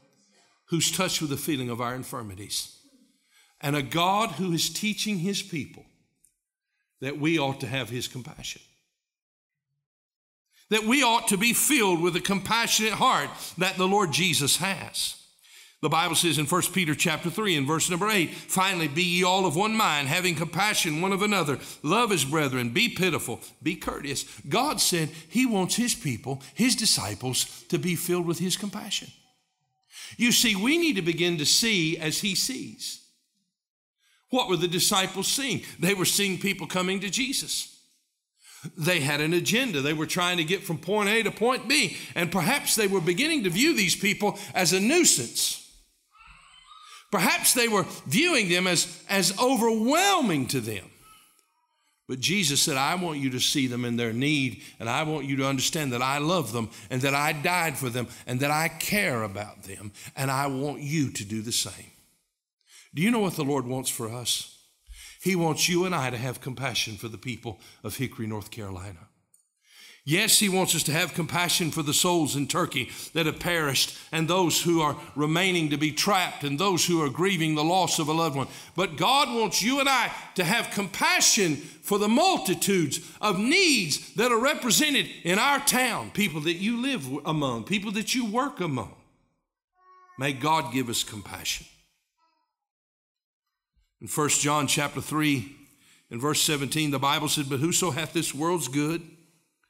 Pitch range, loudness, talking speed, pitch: 145-205 Hz, -25 LUFS, 180 wpm, 170 Hz